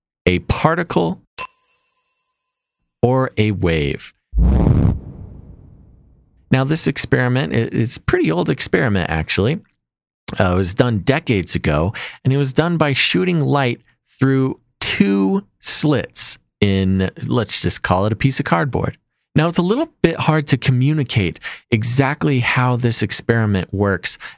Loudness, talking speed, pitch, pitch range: -18 LUFS, 130 wpm, 125 Hz, 100-145 Hz